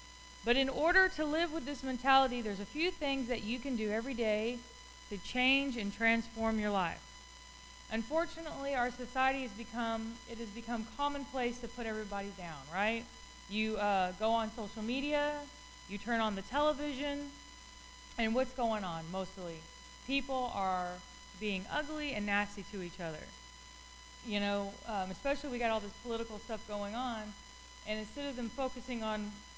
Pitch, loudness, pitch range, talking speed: 225 Hz, -36 LUFS, 200-260 Hz, 160 wpm